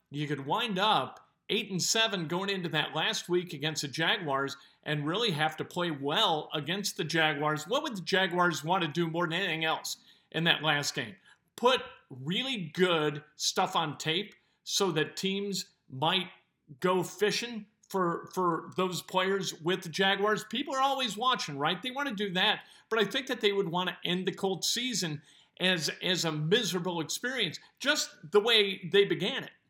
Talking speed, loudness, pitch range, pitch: 185 wpm, -30 LUFS, 160-205 Hz, 185 Hz